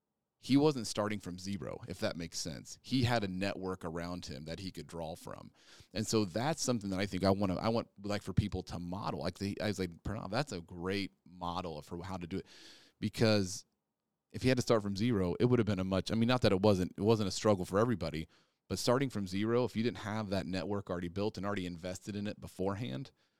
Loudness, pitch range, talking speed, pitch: -35 LUFS, 90-110 Hz, 245 wpm, 100 Hz